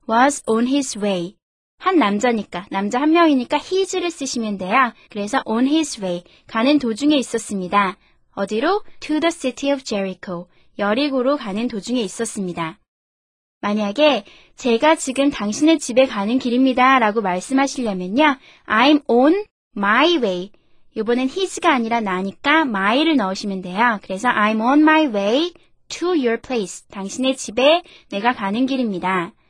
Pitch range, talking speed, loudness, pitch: 205-285 Hz, 370 characters per minute, -19 LUFS, 245 Hz